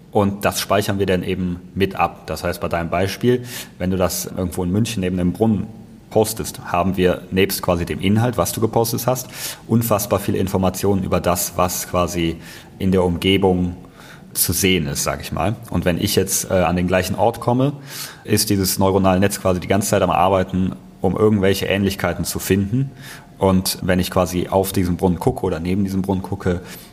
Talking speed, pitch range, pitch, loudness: 195 wpm, 90-100 Hz, 95 Hz, -19 LUFS